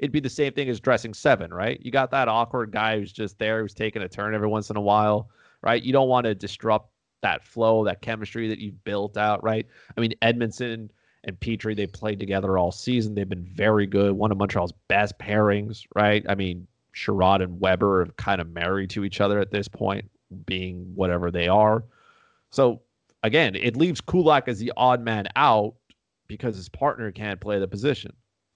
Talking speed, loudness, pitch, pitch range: 205 wpm, -24 LUFS, 105 Hz, 100-115 Hz